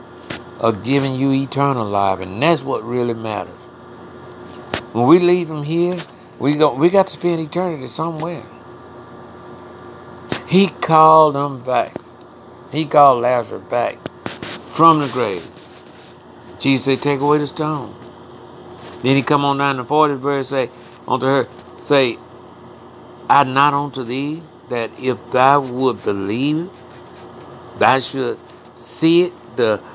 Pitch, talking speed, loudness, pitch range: 135 Hz, 135 wpm, -17 LUFS, 120-150 Hz